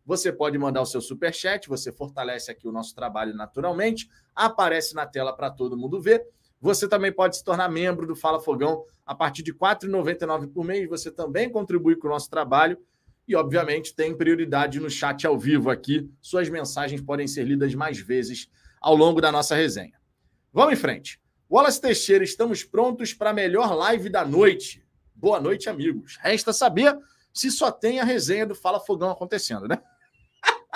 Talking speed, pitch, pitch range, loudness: 180 wpm, 165 Hz, 145-205 Hz, -24 LUFS